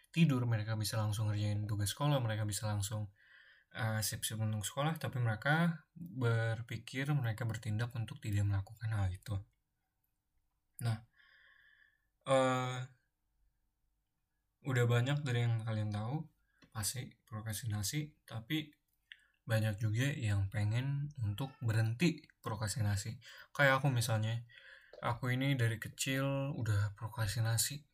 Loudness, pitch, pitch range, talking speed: -36 LUFS, 115 Hz, 110-135 Hz, 110 wpm